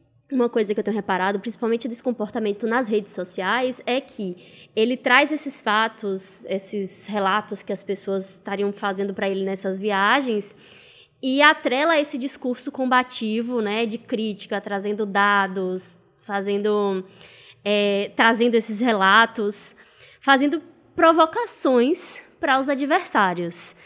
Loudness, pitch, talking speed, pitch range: -22 LUFS, 215 Hz, 125 wpm, 200-255 Hz